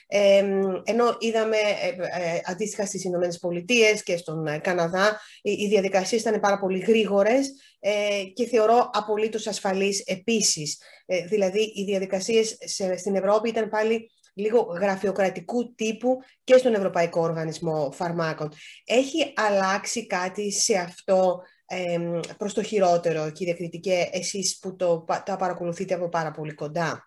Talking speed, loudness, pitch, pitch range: 120 wpm, -24 LUFS, 195 Hz, 175-215 Hz